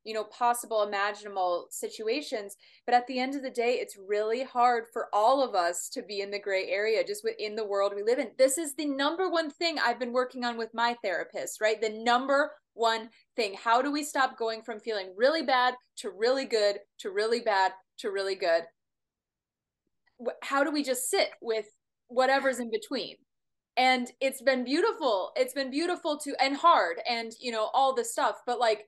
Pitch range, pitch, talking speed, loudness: 215-275 Hz, 245 Hz, 195 wpm, -29 LUFS